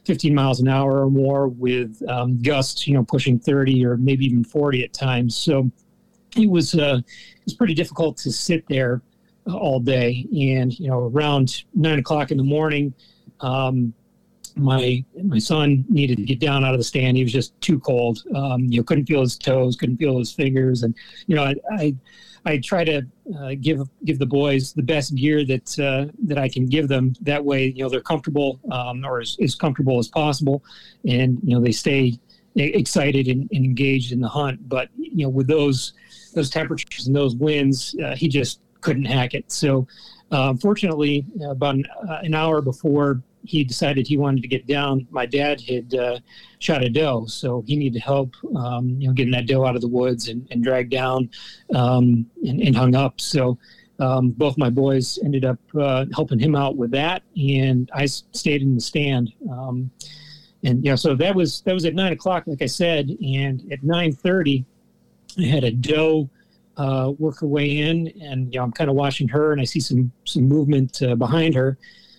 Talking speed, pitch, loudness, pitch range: 205 wpm, 135 Hz, -21 LUFS, 130-155 Hz